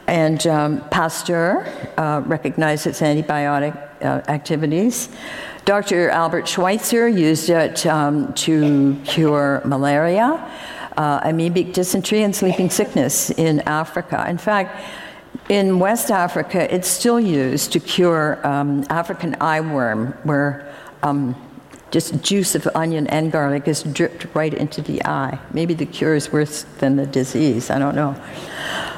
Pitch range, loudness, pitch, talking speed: 145-180 Hz, -19 LUFS, 160 Hz, 135 wpm